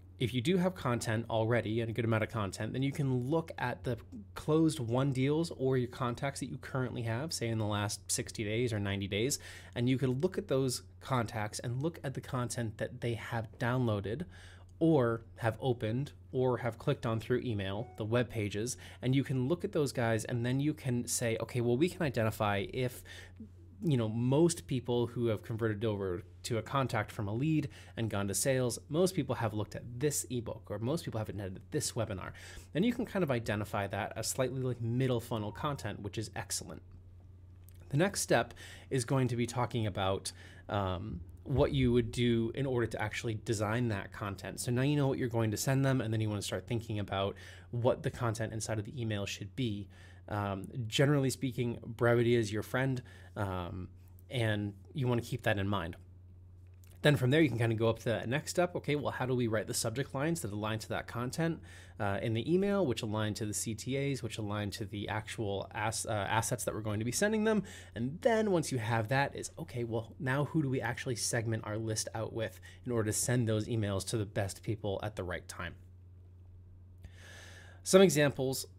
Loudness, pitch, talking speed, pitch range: -34 LUFS, 115 Hz, 215 wpm, 100-130 Hz